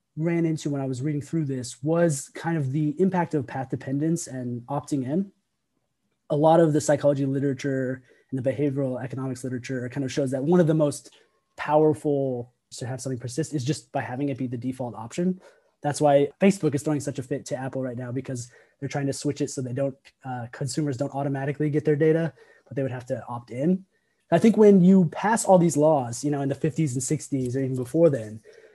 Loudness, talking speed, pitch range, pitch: -25 LUFS, 220 wpm, 130-155 Hz, 140 Hz